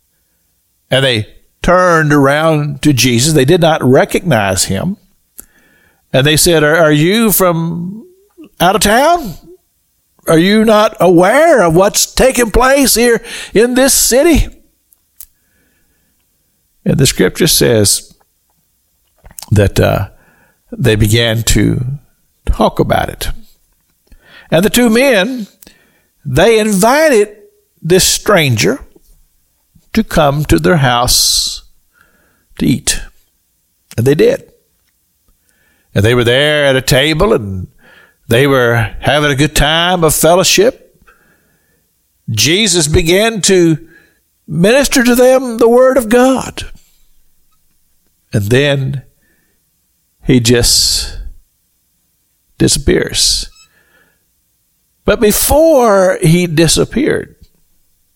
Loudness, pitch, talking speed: -10 LUFS, 150 Hz, 100 wpm